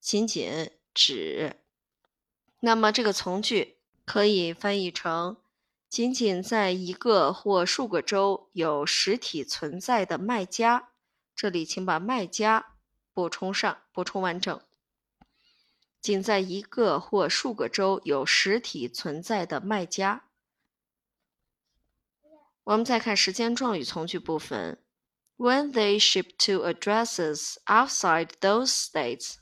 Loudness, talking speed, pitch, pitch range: -26 LUFS, 230 characters per minute, 200 Hz, 180-225 Hz